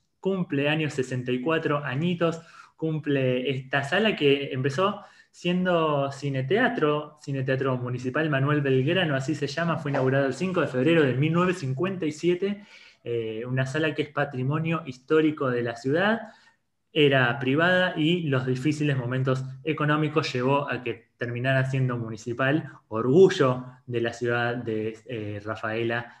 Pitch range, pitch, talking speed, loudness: 130-160 Hz, 140 Hz, 130 wpm, -25 LUFS